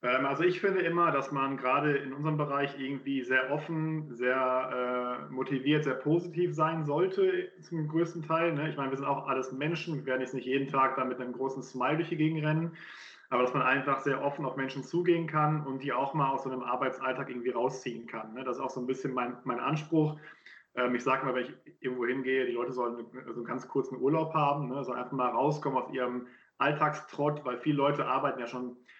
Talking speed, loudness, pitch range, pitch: 230 wpm, -31 LUFS, 130-155 Hz, 135 Hz